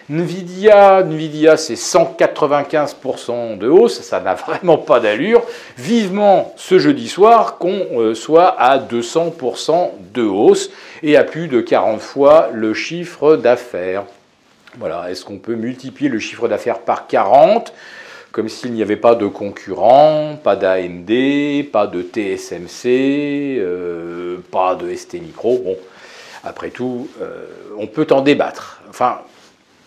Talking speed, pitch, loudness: 135 wpm, 145 Hz, -15 LUFS